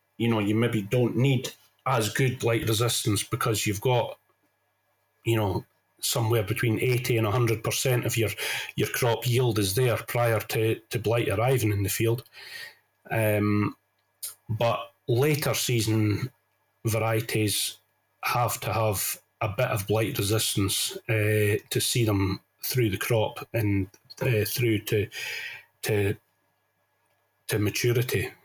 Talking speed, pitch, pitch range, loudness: 130 wpm, 115 Hz, 105-120 Hz, -26 LUFS